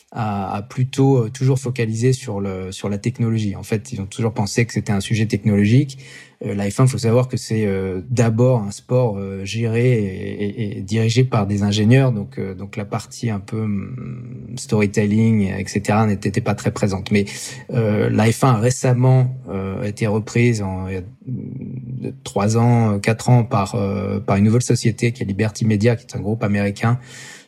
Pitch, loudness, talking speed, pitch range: 110 Hz, -19 LUFS, 185 wpm, 100-120 Hz